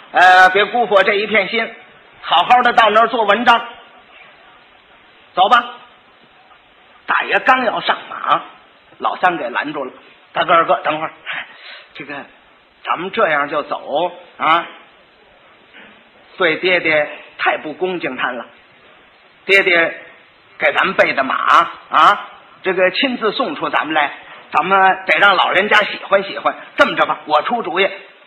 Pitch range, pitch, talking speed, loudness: 185-235 Hz, 200 Hz, 200 characters per minute, -15 LUFS